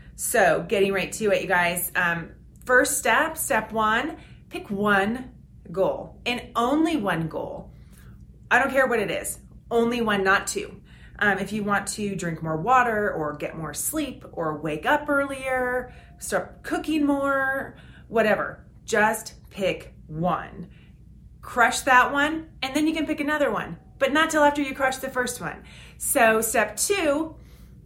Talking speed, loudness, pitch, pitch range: 160 wpm, -24 LUFS, 240 Hz, 200-280 Hz